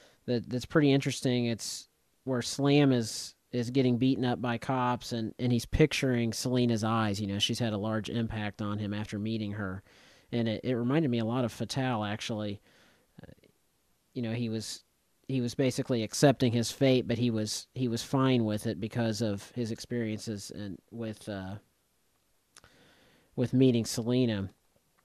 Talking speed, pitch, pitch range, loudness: 170 wpm, 115 Hz, 110-125 Hz, -30 LUFS